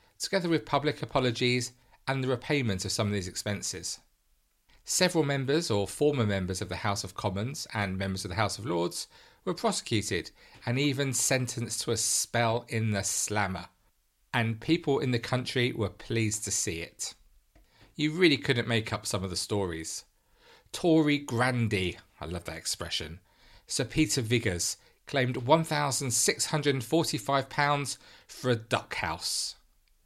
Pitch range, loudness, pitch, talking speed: 100-140 Hz, -29 LUFS, 120 Hz, 160 wpm